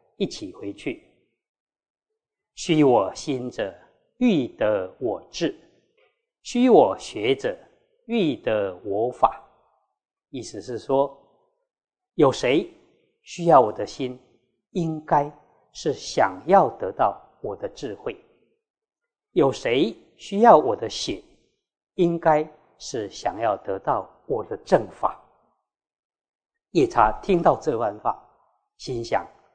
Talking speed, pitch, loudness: 140 characters per minute, 370 Hz, -23 LUFS